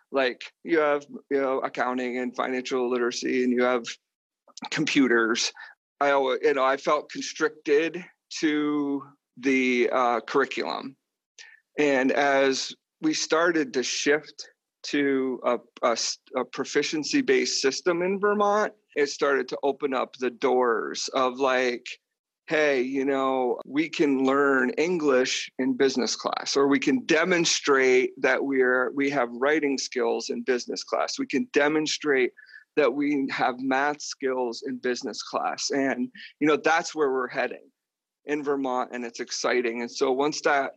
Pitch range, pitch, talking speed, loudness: 130-160 Hz, 140 Hz, 145 wpm, -25 LUFS